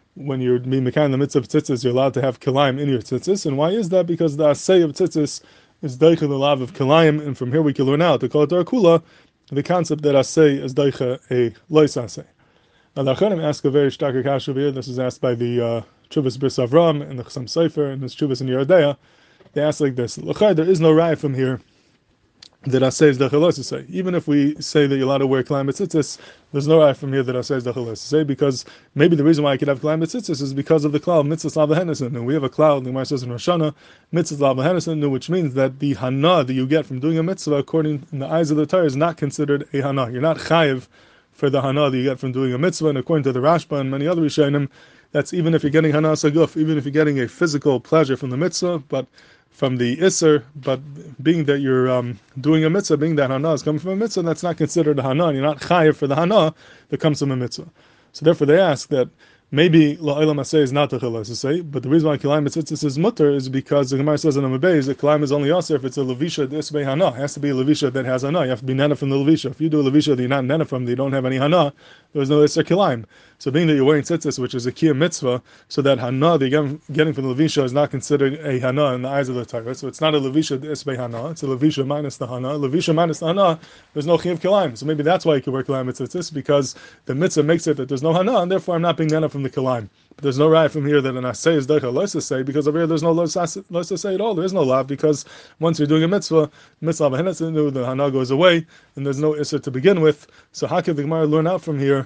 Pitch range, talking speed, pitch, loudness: 135-160 Hz, 260 wpm, 145 Hz, -19 LUFS